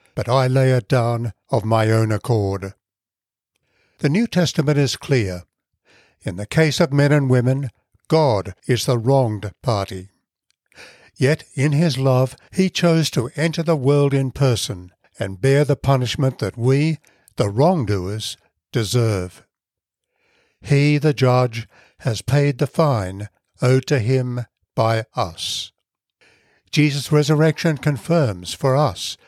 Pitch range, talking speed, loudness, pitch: 110-145 Hz, 130 wpm, -19 LUFS, 130 Hz